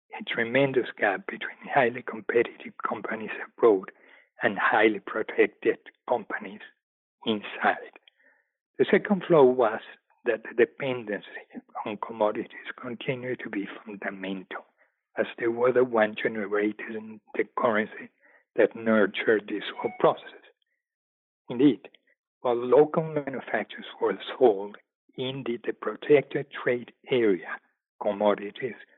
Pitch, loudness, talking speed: 130 Hz, -27 LUFS, 110 wpm